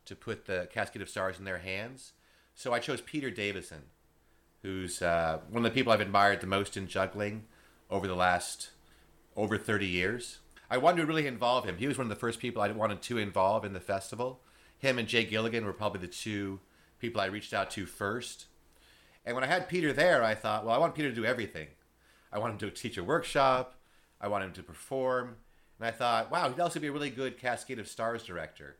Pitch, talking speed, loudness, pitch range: 110 Hz, 225 wpm, -32 LUFS, 95-125 Hz